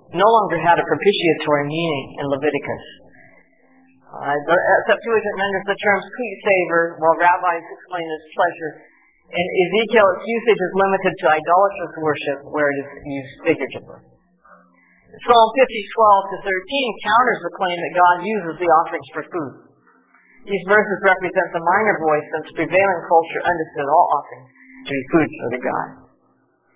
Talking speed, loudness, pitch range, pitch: 150 wpm, -18 LUFS, 155-200 Hz, 175 Hz